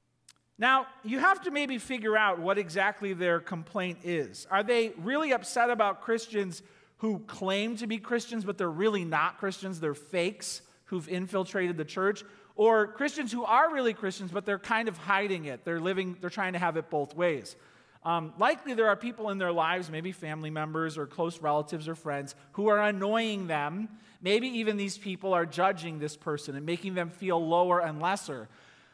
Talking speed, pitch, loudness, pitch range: 185 wpm, 190 Hz, -30 LUFS, 170-215 Hz